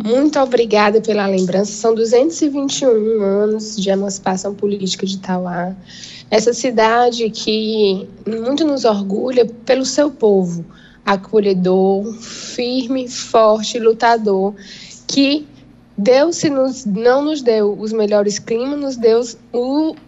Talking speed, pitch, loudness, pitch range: 115 wpm, 220 Hz, -16 LUFS, 200-250 Hz